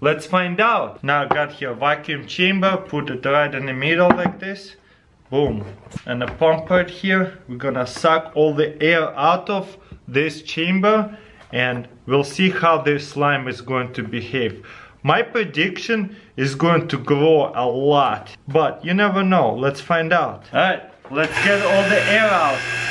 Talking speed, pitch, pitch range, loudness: 170 wpm, 155 Hz, 140-185 Hz, -19 LUFS